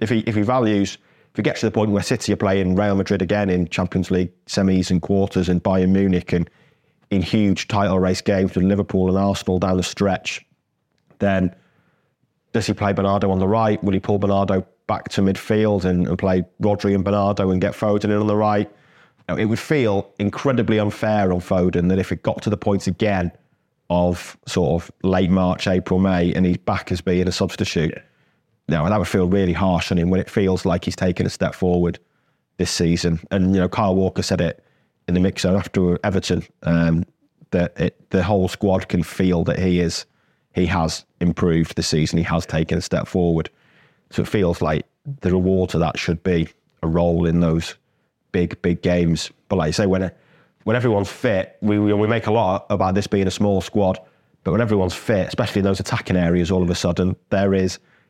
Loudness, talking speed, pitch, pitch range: -20 LUFS, 215 wpm, 95 Hz, 90-105 Hz